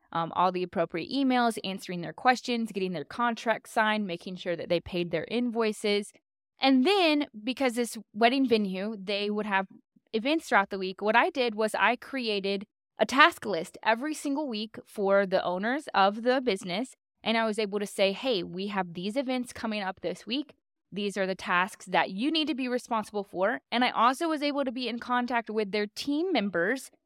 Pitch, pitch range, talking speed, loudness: 220 Hz, 195-255 Hz, 195 wpm, -28 LUFS